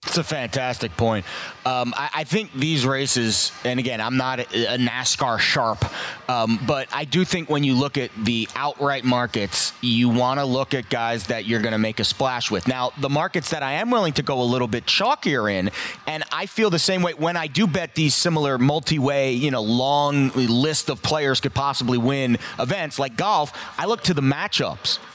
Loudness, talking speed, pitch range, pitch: -22 LUFS, 210 wpm, 125-155 Hz, 135 Hz